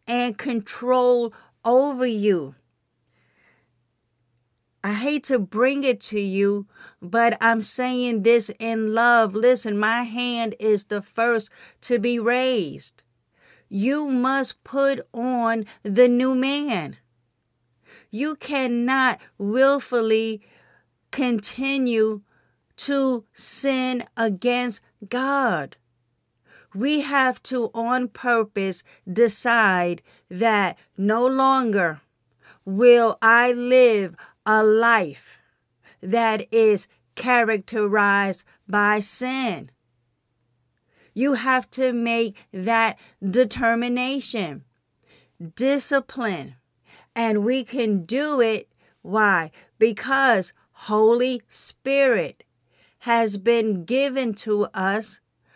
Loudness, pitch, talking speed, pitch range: -21 LUFS, 230 Hz, 85 wpm, 200-250 Hz